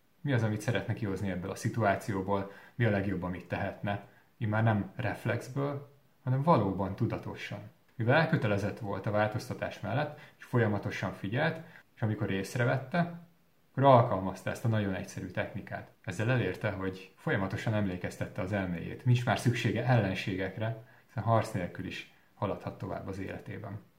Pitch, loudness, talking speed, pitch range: 110 Hz, -32 LUFS, 145 wpm, 100-125 Hz